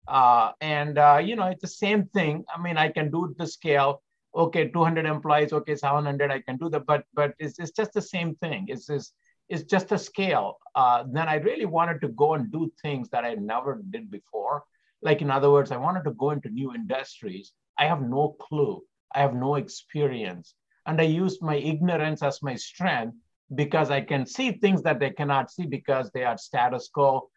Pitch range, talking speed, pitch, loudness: 140-175 Hz, 210 wpm, 155 Hz, -26 LUFS